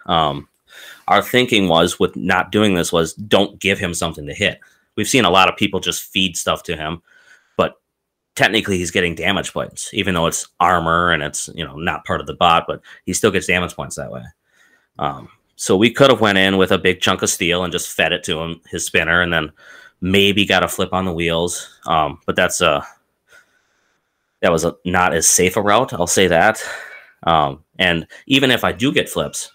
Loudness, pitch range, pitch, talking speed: -17 LUFS, 85-100 Hz, 90 Hz, 215 wpm